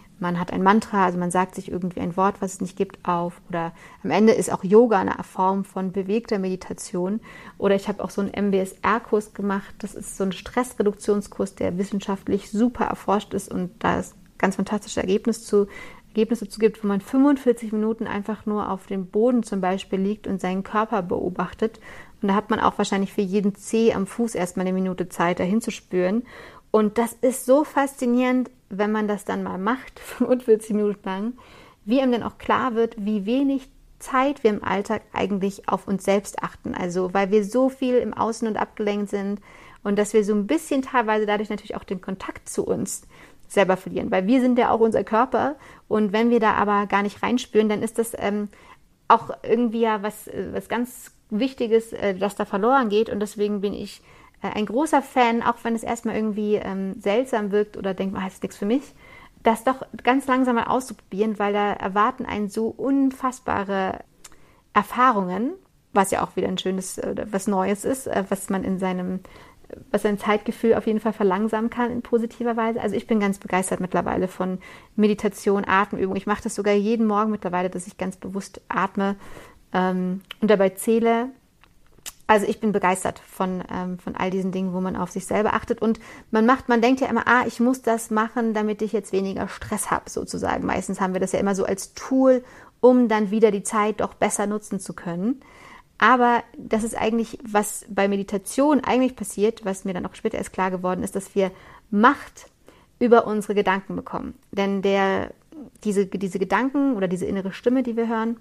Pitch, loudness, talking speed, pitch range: 210 Hz, -23 LUFS, 195 wpm, 195-230 Hz